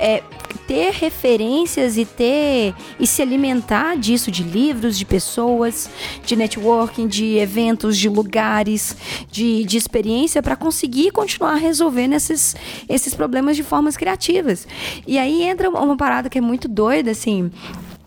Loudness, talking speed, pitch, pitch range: -18 LUFS, 140 wpm, 245 Hz, 220-295 Hz